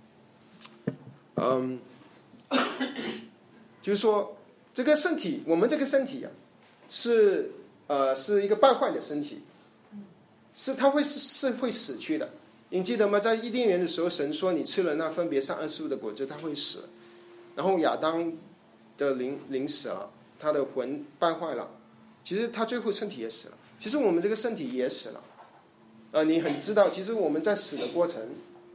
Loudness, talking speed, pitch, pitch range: -28 LUFS, 240 characters per minute, 175 Hz, 145-240 Hz